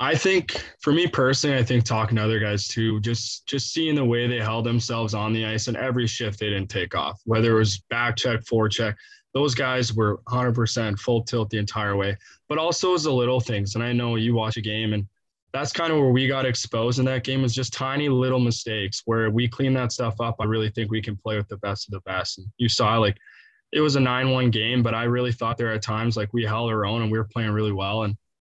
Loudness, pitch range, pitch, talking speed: -24 LUFS, 110-125 Hz, 115 Hz, 260 wpm